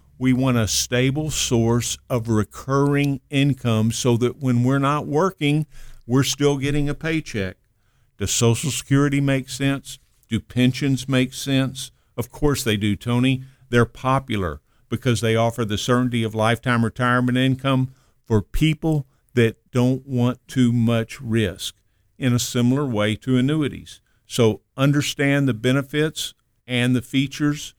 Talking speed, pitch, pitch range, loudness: 140 wpm, 125 Hz, 115-135 Hz, -21 LUFS